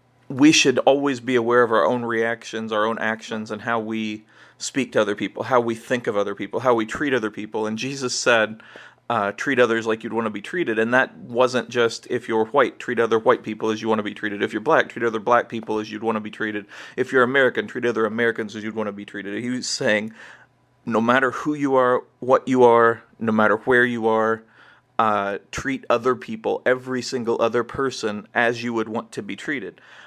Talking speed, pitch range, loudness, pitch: 230 wpm, 110-125 Hz, -21 LUFS, 115 Hz